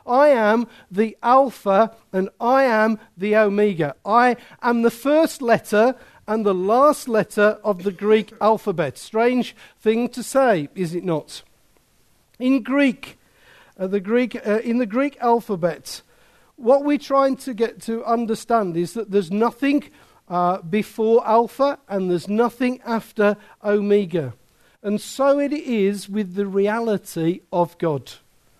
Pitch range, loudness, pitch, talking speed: 200-245 Hz, -20 LUFS, 220 Hz, 140 wpm